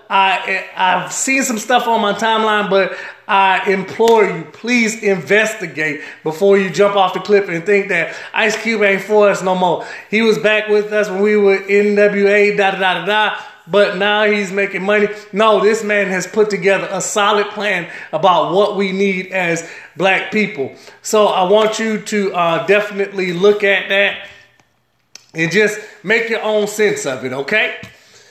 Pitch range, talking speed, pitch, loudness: 190-210 Hz, 180 wpm, 205 Hz, -15 LUFS